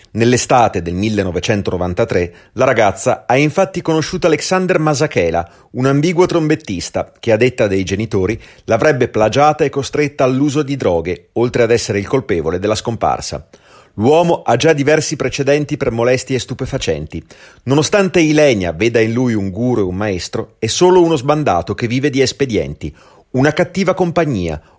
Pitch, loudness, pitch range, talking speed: 130 Hz, -15 LUFS, 105-150 Hz, 150 wpm